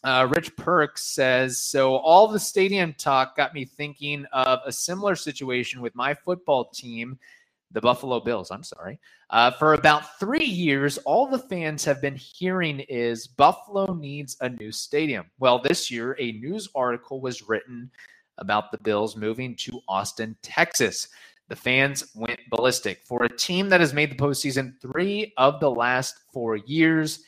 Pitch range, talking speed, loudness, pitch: 125-155 Hz, 165 wpm, -23 LUFS, 135 Hz